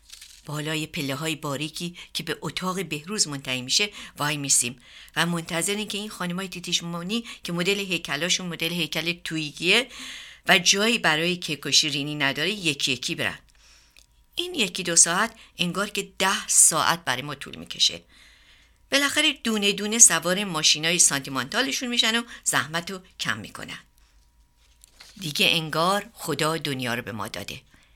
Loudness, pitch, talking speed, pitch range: -23 LUFS, 165 Hz, 145 wpm, 145-200 Hz